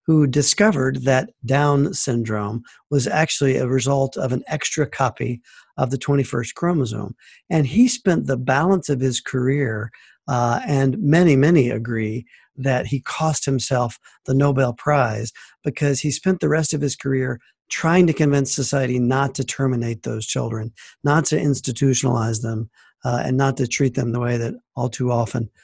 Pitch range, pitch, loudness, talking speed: 120-145 Hz, 135 Hz, -20 LUFS, 165 wpm